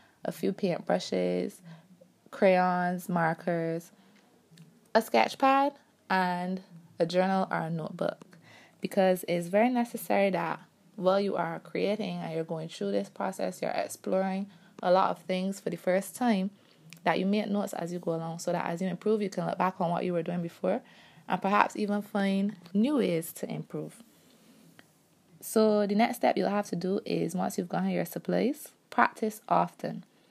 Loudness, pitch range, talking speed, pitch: -30 LUFS, 175-205 Hz, 170 wpm, 185 Hz